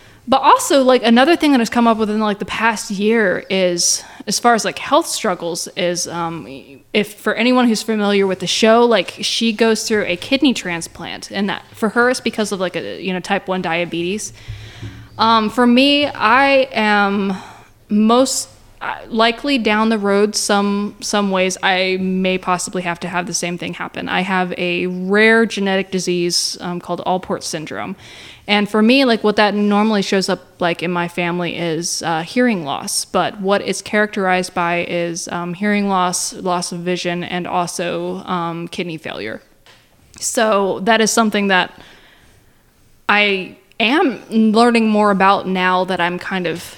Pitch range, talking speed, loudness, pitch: 175-220 Hz, 175 wpm, -16 LUFS, 195 Hz